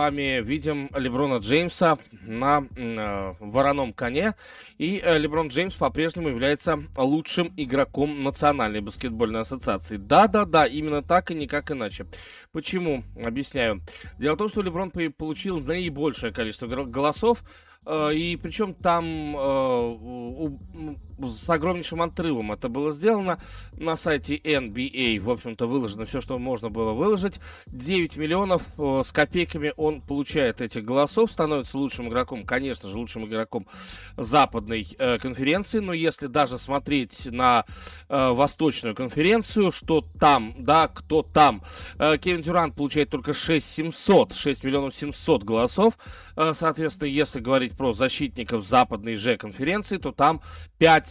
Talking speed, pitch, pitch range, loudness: 135 wpm, 145 Hz, 125-160 Hz, -24 LUFS